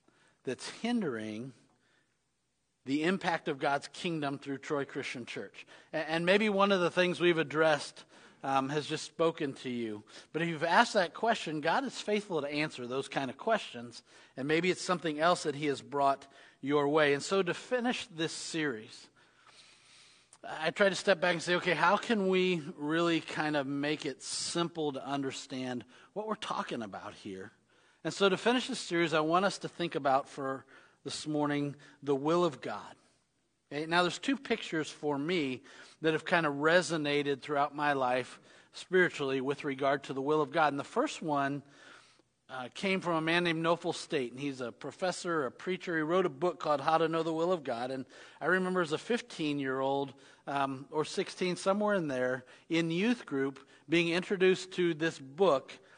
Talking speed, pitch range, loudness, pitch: 190 wpm, 140-180 Hz, -32 LUFS, 155 Hz